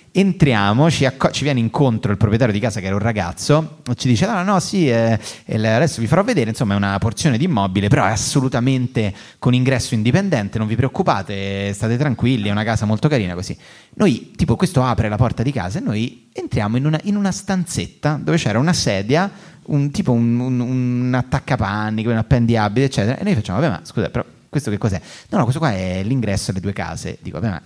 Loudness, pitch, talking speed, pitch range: -18 LUFS, 120 Hz, 215 wpm, 110-145 Hz